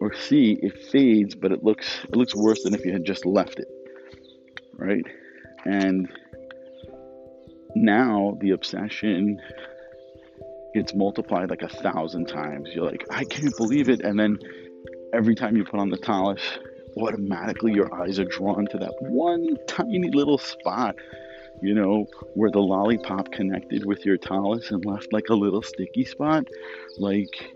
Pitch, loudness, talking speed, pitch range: 100 Hz, -24 LUFS, 155 wpm, 95-130 Hz